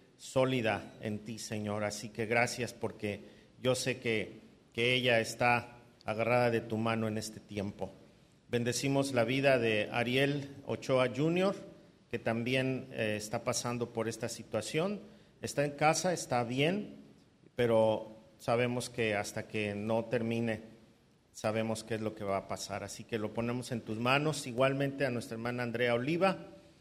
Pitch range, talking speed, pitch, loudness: 110-130 Hz, 155 wpm, 115 Hz, -33 LUFS